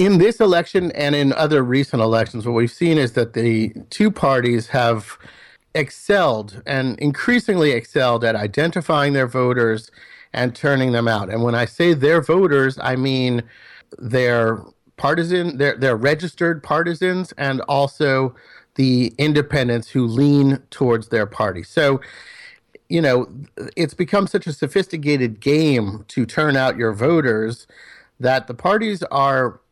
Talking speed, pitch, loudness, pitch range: 140 wpm, 135 Hz, -18 LUFS, 120-160 Hz